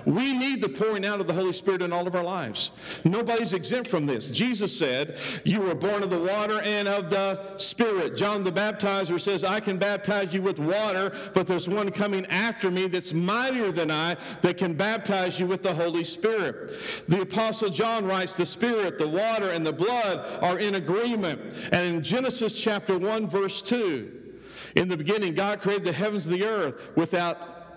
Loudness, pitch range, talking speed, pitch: -26 LUFS, 180-215 Hz, 195 wpm, 195 Hz